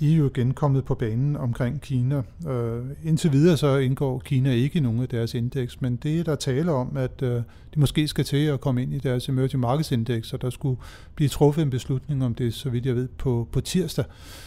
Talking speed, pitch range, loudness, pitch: 230 wpm, 125-145 Hz, -25 LUFS, 130 Hz